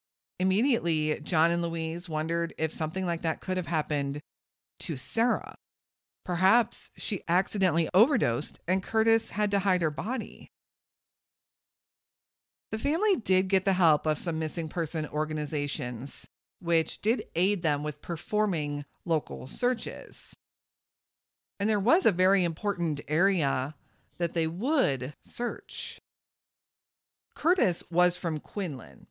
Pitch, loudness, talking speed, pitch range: 170 Hz, -28 LUFS, 120 wpm, 155-195 Hz